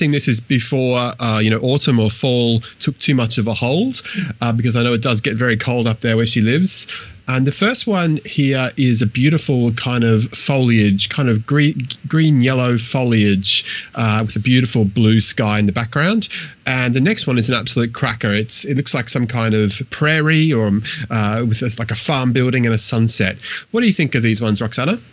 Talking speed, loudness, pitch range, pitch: 215 wpm, -16 LUFS, 115-140 Hz, 125 Hz